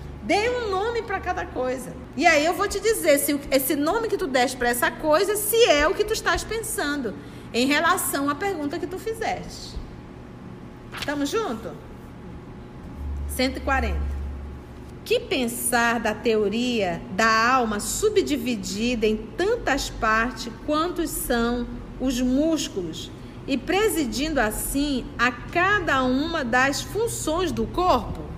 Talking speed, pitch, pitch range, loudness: 130 wpm, 290 Hz, 235-360 Hz, -23 LUFS